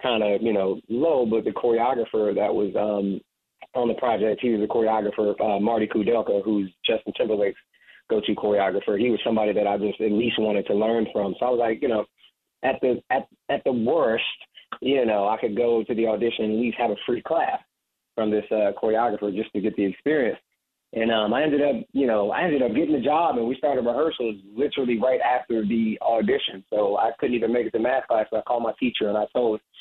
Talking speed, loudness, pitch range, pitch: 225 wpm, -24 LUFS, 105-120 Hz, 110 Hz